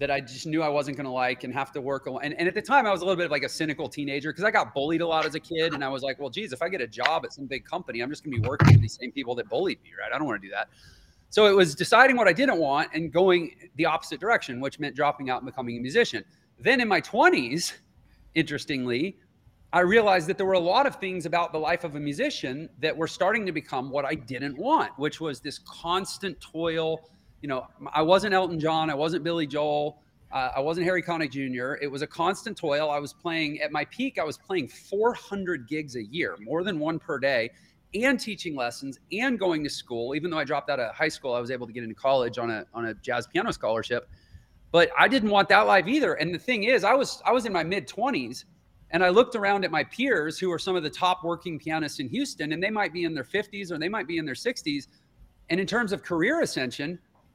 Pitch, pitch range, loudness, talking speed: 160 Hz, 145-190 Hz, -26 LUFS, 260 wpm